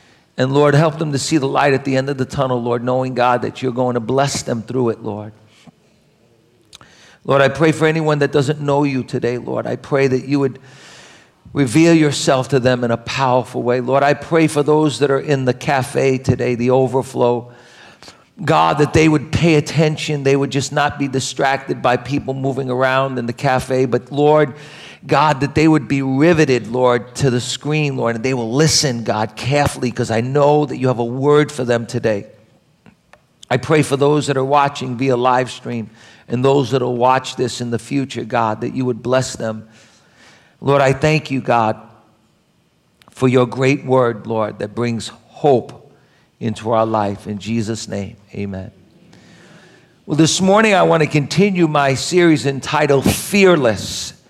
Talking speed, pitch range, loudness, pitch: 185 wpm, 120-145 Hz, -16 LUFS, 130 Hz